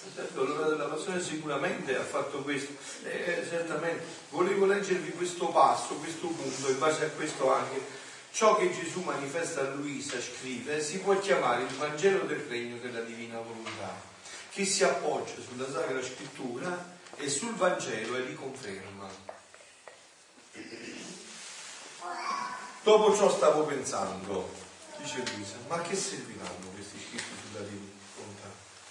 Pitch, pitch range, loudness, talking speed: 145 Hz, 120-180 Hz, -31 LUFS, 125 wpm